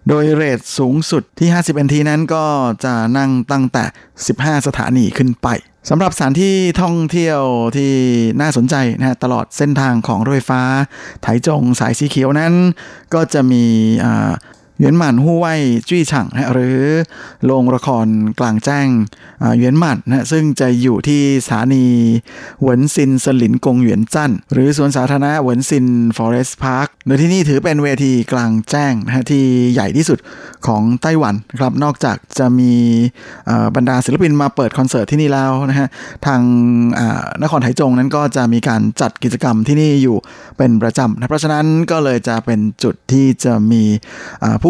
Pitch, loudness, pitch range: 130 Hz, -14 LUFS, 120-145 Hz